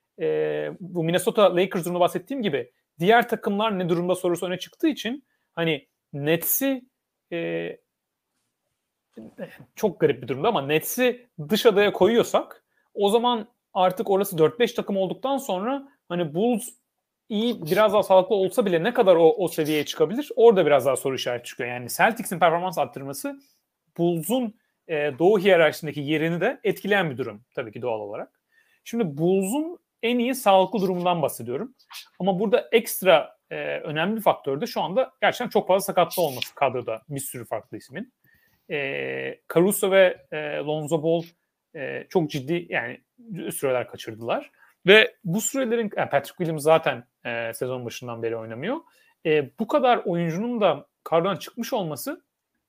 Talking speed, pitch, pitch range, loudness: 150 wpm, 185 Hz, 155-230 Hz, -23 LUFS